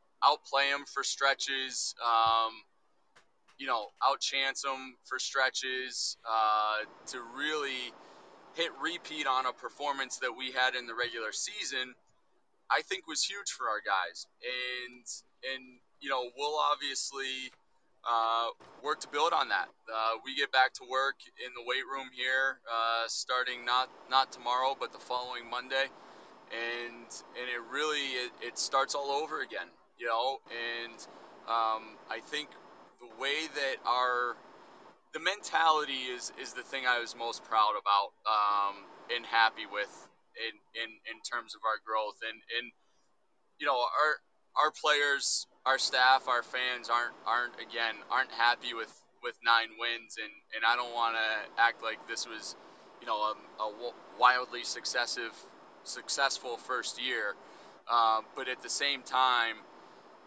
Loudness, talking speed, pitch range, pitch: -32 LUFS, 150 wpm, 115-135 Hz, 125 Hz